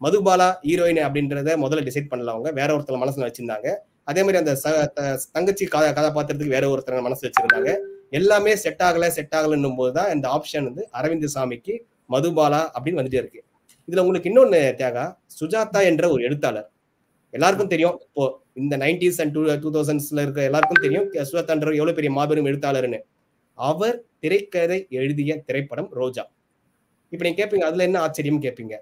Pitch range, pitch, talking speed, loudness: 140-180 Hz, 155 Hz, 150 wpm, -21 LUFS